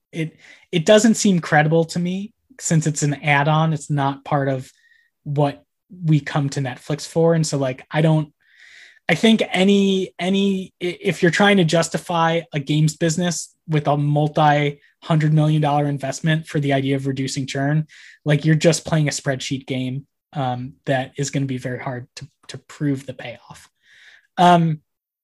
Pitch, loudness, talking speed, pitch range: 150 Hz, -20 LUFS, 180 wpm, 140-170 Hz